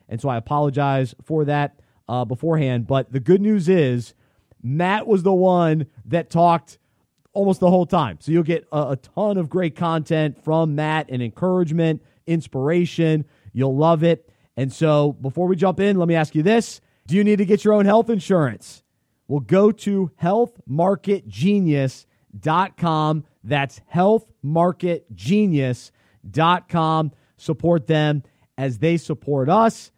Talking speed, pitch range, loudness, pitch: 145 wpm, 135-180 Hz, -20 LUFS, 160 Hz